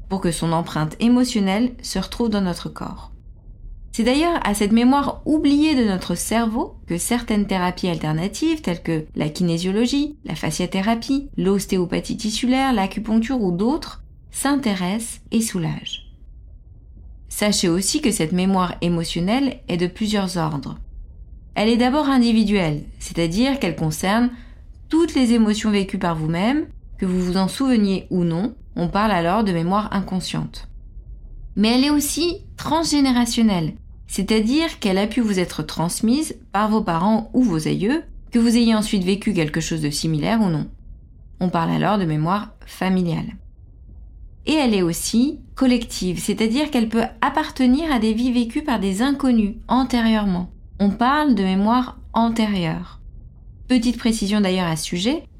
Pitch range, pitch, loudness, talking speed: 180-245 Hz, 210 Hz, -20 LUFS, 145 wpm